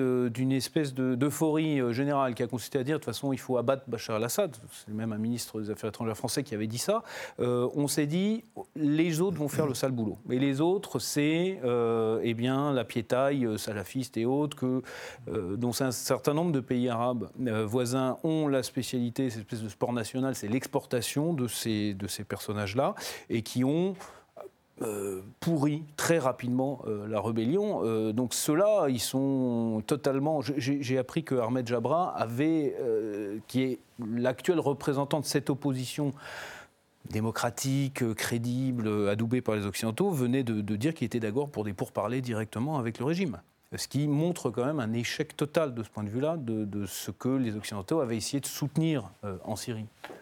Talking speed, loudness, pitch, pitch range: 185 wpm, -30 LUFS, 125 Hz, 115-145 Hz